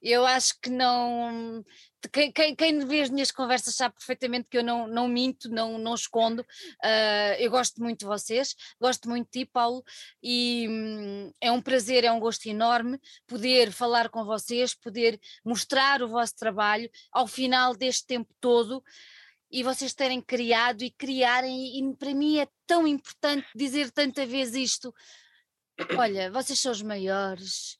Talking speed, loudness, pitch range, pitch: 160 wpm, -26 LUFS, 230-260 Hz, 245 Hz